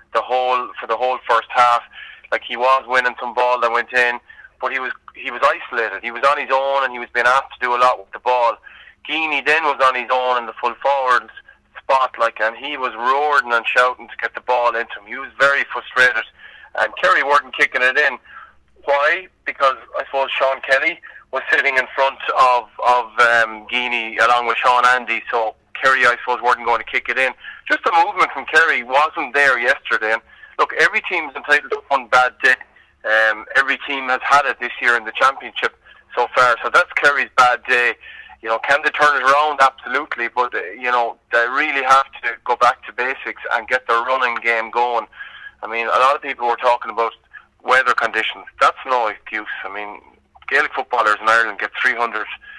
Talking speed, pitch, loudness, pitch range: 210 wpm, 125 Hz, -17 LUFS, 120-140 Hz